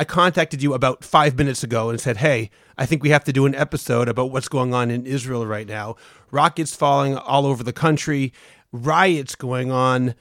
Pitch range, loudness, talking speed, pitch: 125-150 Hz, -20 LUFS, 205 wpm, 135 Hz